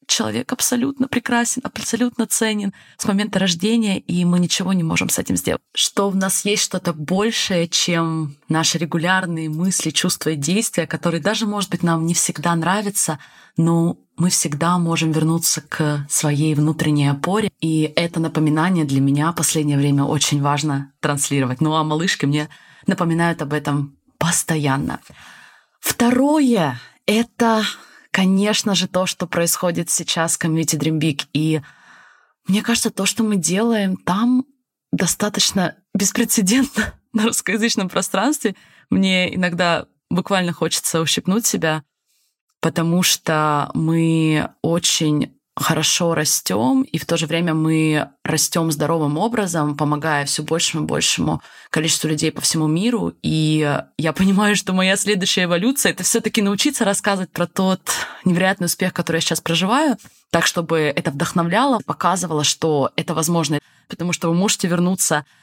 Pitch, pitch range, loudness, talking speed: 170 Hz, 155-200 Hz, -19 LUFS, 140 wpm